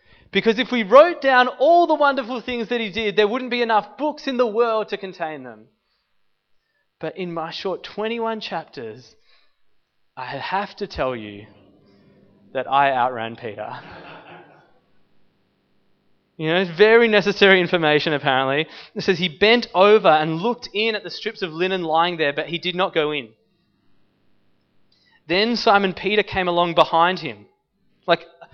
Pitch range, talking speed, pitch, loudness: 155-225 Hz, 155 wpm, 185 Hz, -19 LUFS